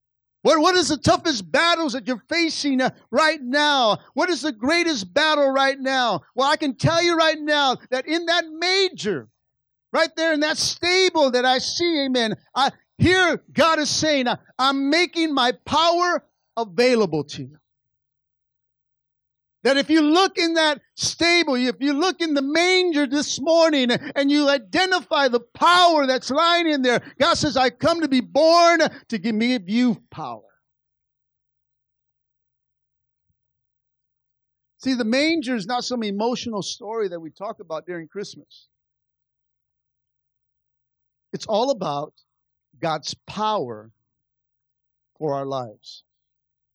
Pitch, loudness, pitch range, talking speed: 275 Hz, -20 LUFS, 230-320 Hz, 140 wpm